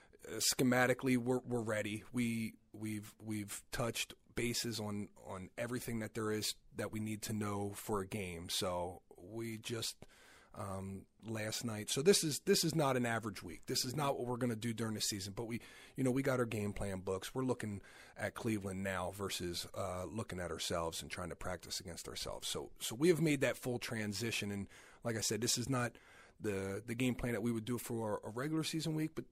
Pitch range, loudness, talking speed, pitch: 100-125 Hz, -39 LUFS, 215 wpm, 110 Hz